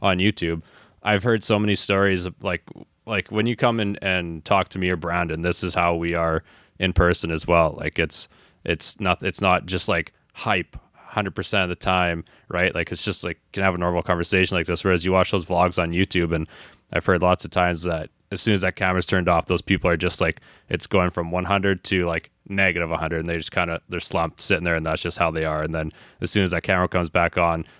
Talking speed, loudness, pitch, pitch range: 245 wpm, -22 LUFS, 90 Hz, 85-95 Hz